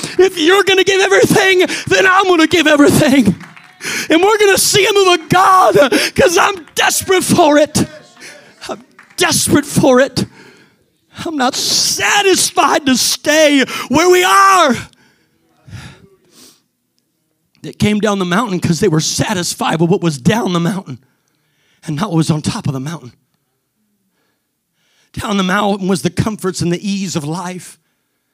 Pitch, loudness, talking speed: 210 Hz, -12 LUFS, 155 wpm